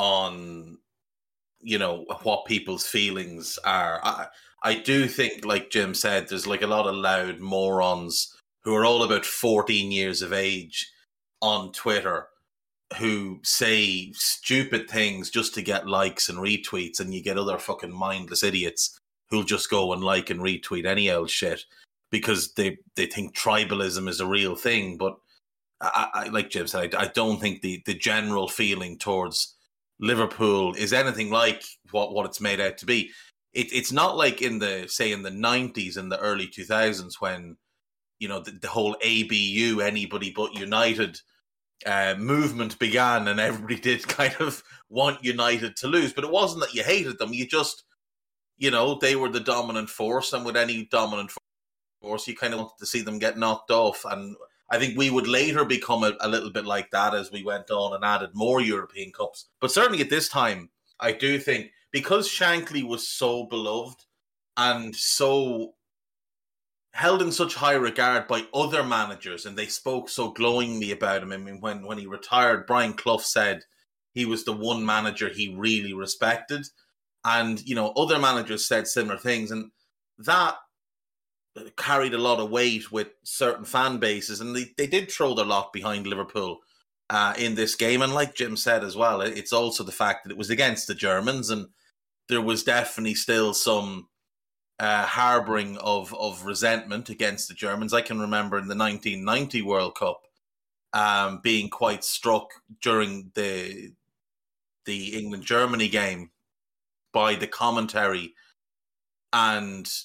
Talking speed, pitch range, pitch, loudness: 170 wpm, 100-120 Hz, 110 Hz, -25 LUFS